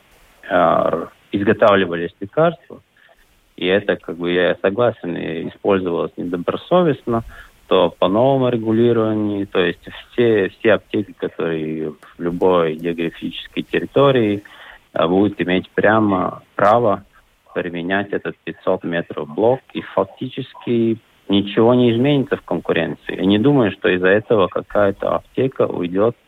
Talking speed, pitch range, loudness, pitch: 110 wpm, 90-120 Hz, -18 LUFS, 100 Hz